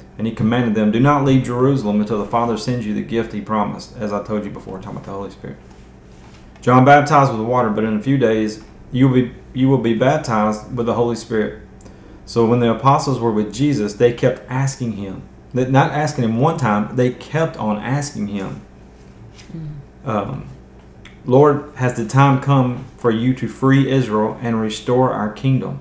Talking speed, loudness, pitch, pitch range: 195 wpm, -17 LUFS, 115 Hz, 105-130 Hz